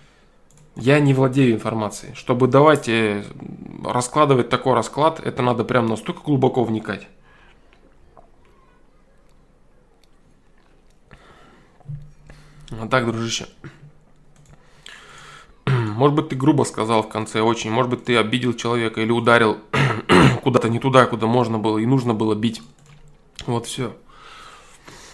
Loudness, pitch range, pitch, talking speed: -19 LUFS, 115-145 Hz, 125 Hz, 110 wpm